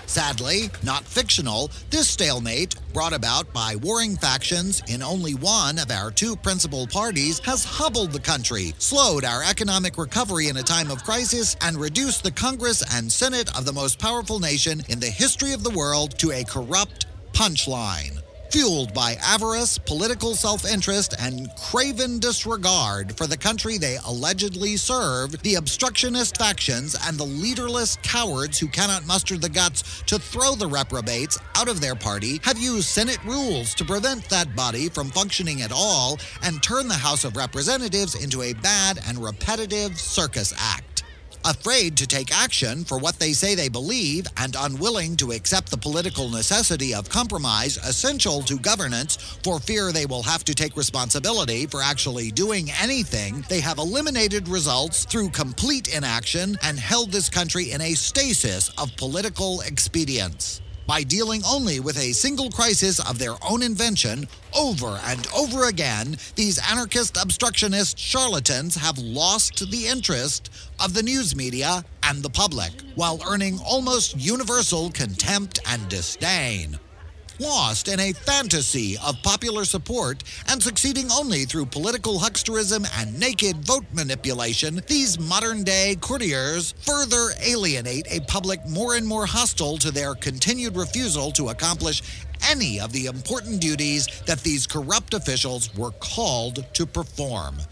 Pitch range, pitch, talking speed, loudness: 130-215 Hz, 165 Hz, 150 wpm, -22 LUFS